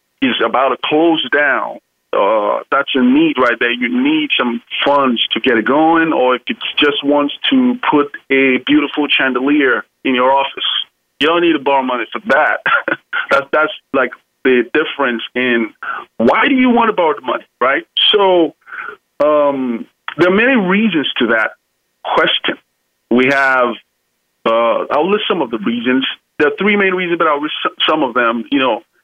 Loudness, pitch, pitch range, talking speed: -14 LUFS, 145 Hz, 125-195 Hz, 180 wpm